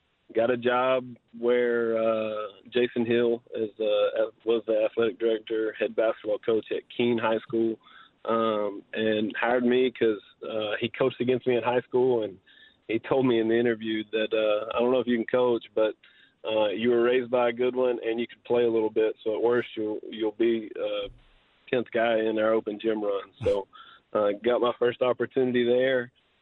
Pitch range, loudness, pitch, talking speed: 110-125 Hz, -26 LUFS, 120 Hz, 195 wpm